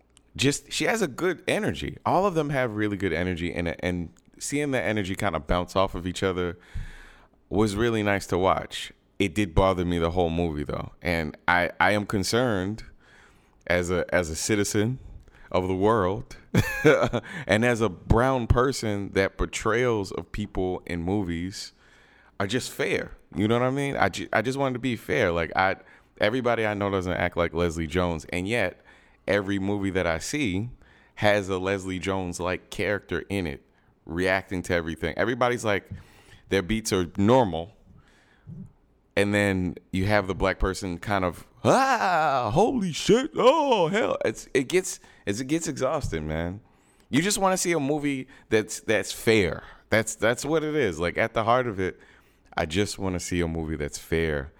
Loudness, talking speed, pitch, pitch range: -26 LUFS, 180 wpm, 100 Hz, 90-115 Hz